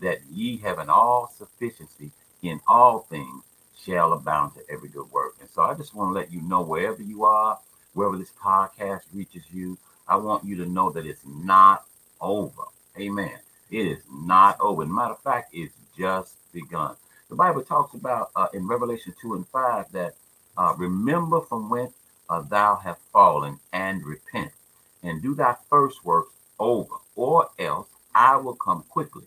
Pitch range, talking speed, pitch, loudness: 90-125 Hz, 180 wpm, 100 Hz, -23 LUFS